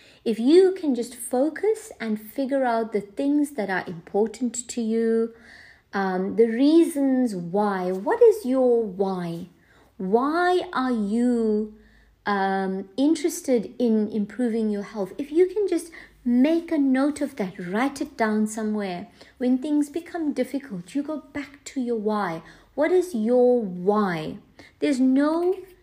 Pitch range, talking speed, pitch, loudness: 210-290 Hz, 140 wpm, 245 Hz, -24 LUFS